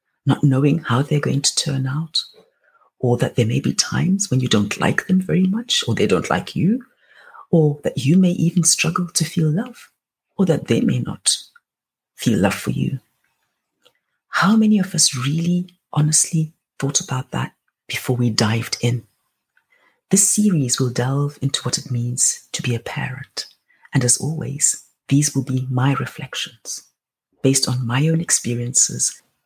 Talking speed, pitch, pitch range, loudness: 165 wpm, 145 Hz, 130-175 Hz, -19 LUFS